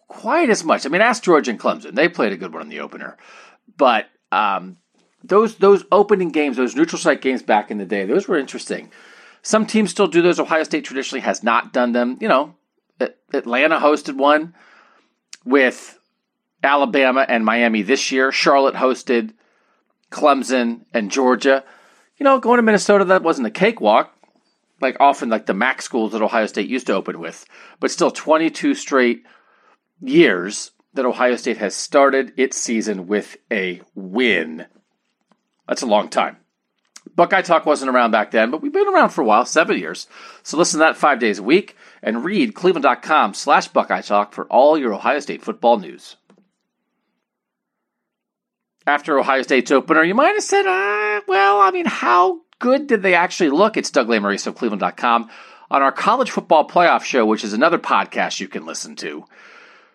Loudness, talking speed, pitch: -17 LUFS, 175 wpm, 150 Hz